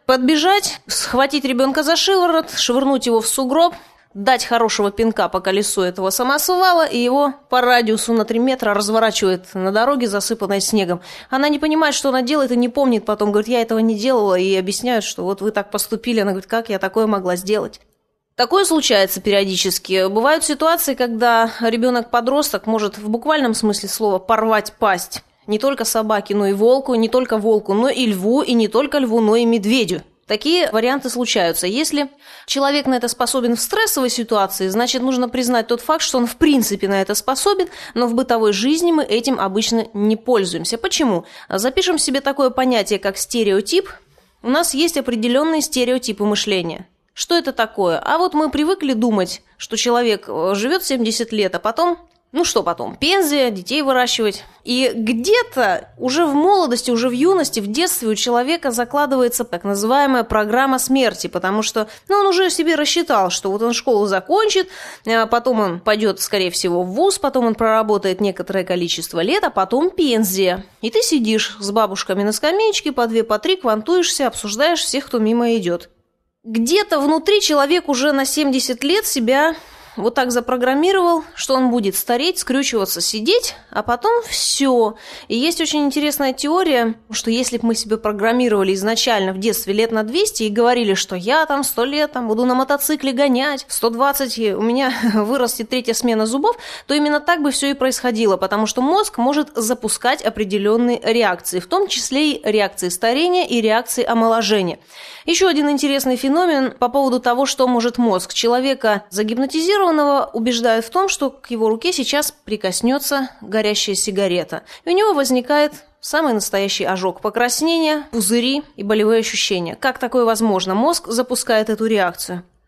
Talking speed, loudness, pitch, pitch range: 165 wpm, -17 LUFS, 240 Hz, 215-285 Hz